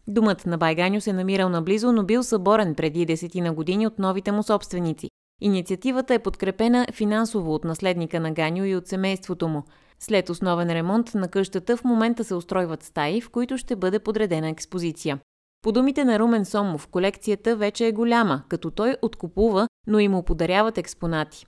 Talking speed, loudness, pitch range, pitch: 170 wpm, -23 LUFS, 175-220 Hz, 195 Hz